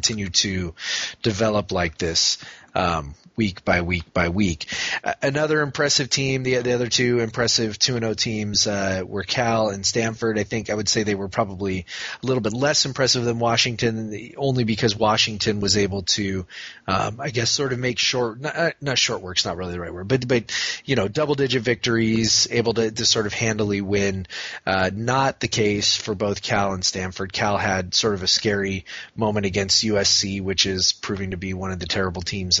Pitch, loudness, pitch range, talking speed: 110 Hz, -21 LUFS, 95-120 Hz, 200 wpm